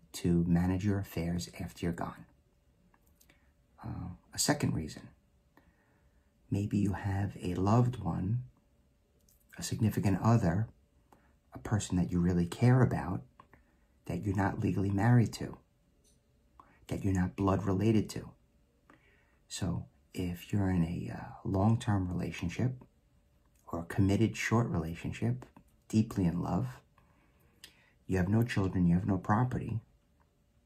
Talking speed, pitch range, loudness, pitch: 125 wpm, 85-110 Hz, -32 LUFS, 95 Hz